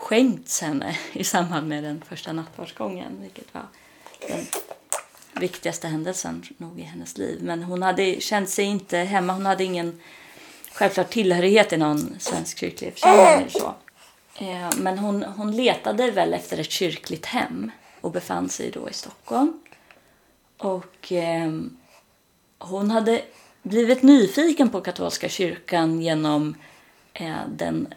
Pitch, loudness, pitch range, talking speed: 185 Hz, -23 LUFS, 165-215 Hz, 125 wpm